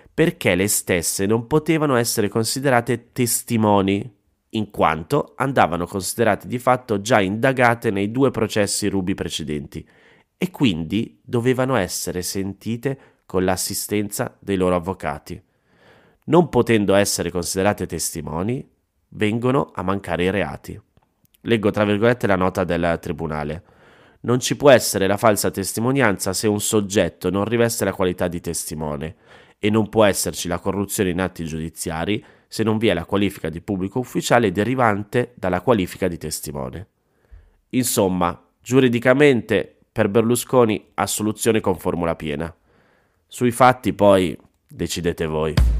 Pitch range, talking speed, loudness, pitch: 90-115 Hz, 130 wpm, -20 LUFS, 100 Hz